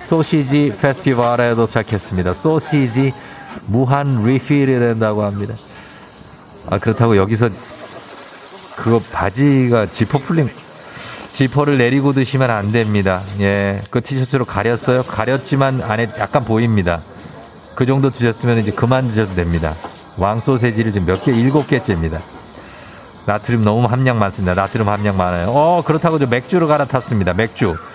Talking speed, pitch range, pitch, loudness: 315 characters per minute, 100-135 Hz, 115 Hz, -16 LUFS